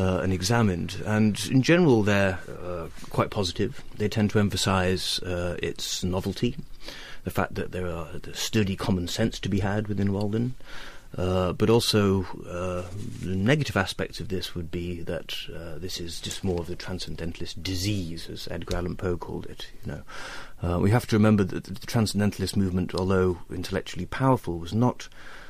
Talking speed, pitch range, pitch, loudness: 165 wpm, 90-105 Hz, 95 Hz, -27 LUFS